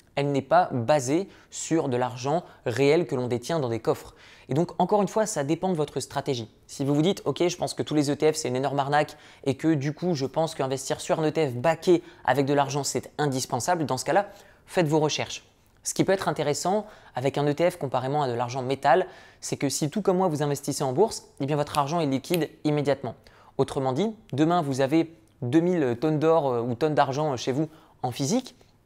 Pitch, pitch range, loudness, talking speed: 145 Hz, 135-165 Hz, -26 LUFS, 220 wpm